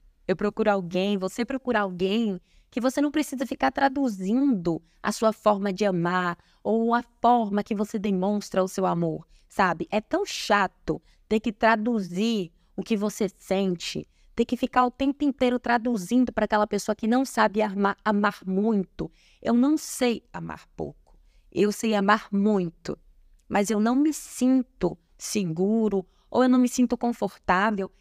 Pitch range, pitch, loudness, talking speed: 195-240 Hz, 215 Hz, -25 LUFS, 160 wpm